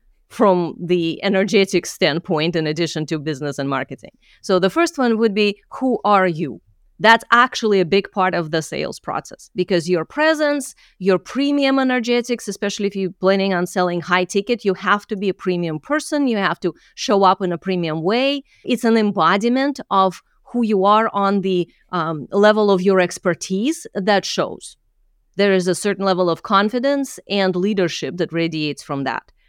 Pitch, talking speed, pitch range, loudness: 190 Hz, 175 wpm, 175-220 Hz, -19 LUFS